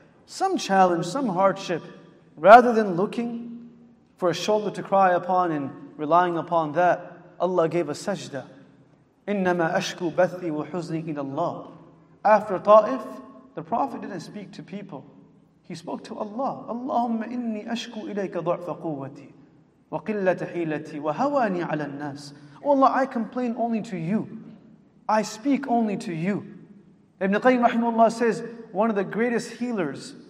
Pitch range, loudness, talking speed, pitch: 170-225 Hz, -24 LUFS, 130 wpm, 195 Hz